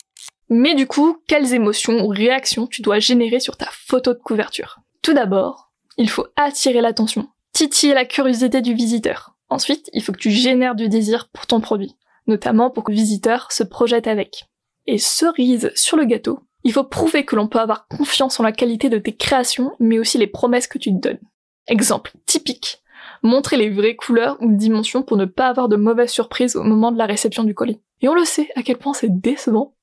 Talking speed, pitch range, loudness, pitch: 205 wpm, 220-265 Hz, -17 LUFS, 240 Hz